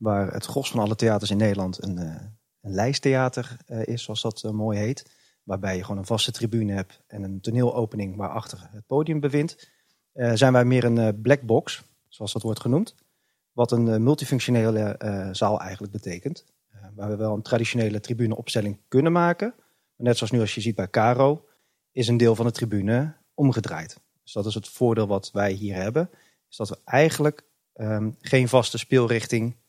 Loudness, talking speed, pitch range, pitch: -24 LUFS, 180 wpm, 105-125 Hz, 115 Hz